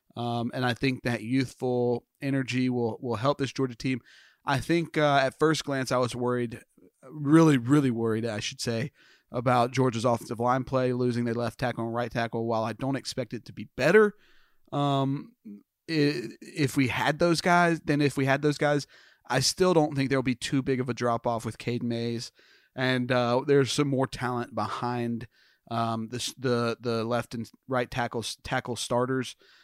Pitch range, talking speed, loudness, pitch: 120-140 Hz, 185 wpm, -27 LUFS, 125 Hz